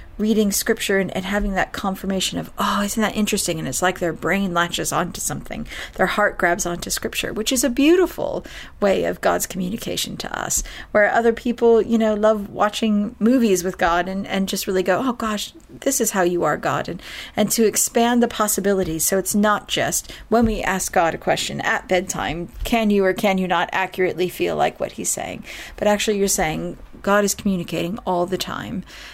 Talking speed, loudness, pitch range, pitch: 200 wpm, -20 LUFS, 185-220 Hz, 200 Hz